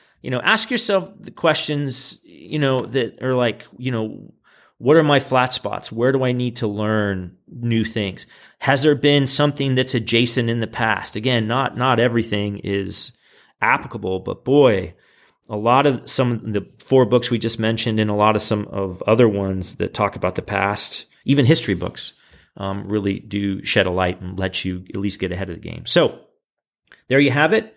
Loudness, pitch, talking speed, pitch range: -19 LUFS, 115 Hz, 195 wpm, 100-135 Hz